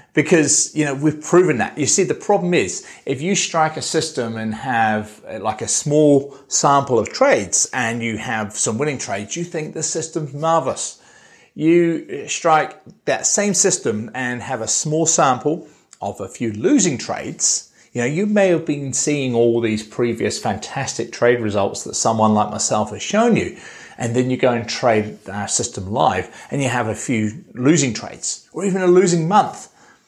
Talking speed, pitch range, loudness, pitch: 180 wpm, 115-165 Hz, -18 LUFS, 140 Hz